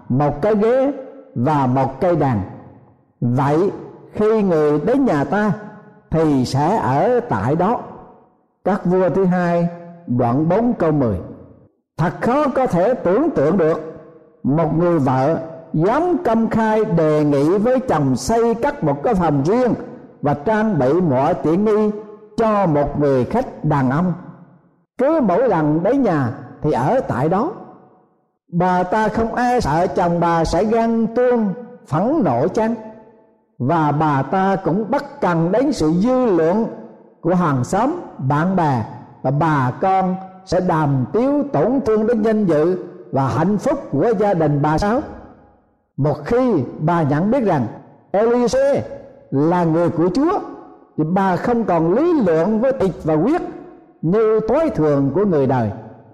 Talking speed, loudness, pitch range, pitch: 155 wpm, -18 LUFS, 150-225 Hz, 175 Hz